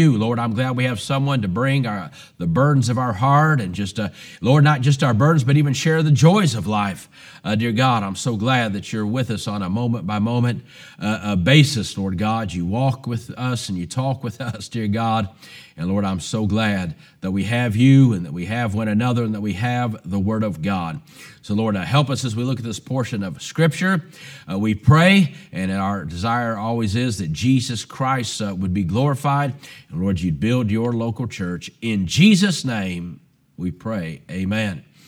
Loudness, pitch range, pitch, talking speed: -20 LUFS, 105-135 Hz, 115 Hz, 210 wpm